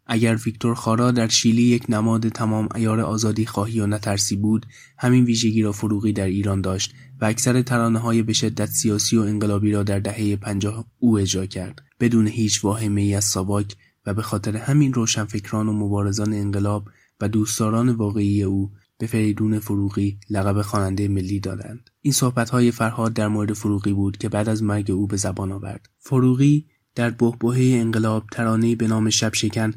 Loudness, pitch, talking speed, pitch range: -21 LUFS, 110 Hz, 175 wpm, 100-115 Hz